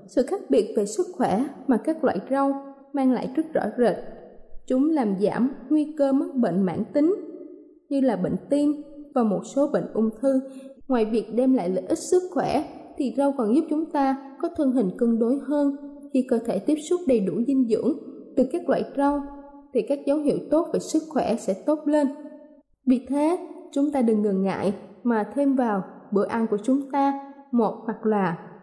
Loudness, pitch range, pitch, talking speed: -24 LUFS, 230-295 Hz, 270 Hz, 200 wpm